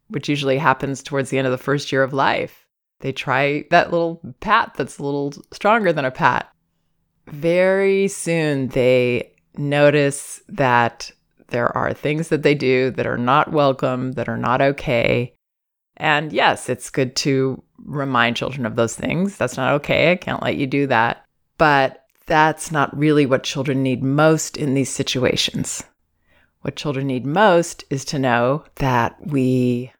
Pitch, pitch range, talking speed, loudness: 135 Hz, 125-150 Hz, 165 wpm, -19 LUFS